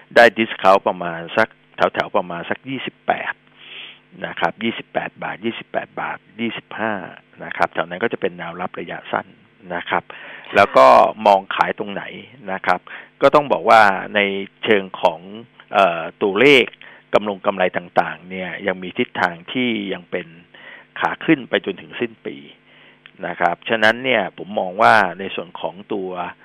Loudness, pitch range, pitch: -19 LUFS, 90-115 Hz, 95 Hz